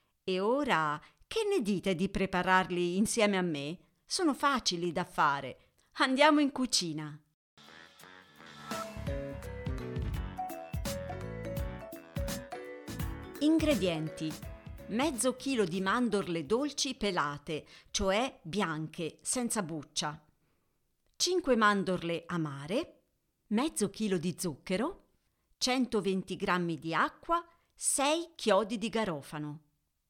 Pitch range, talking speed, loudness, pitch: 155-245 Hz, 85 wpm, -32 LUFS, 185 Hz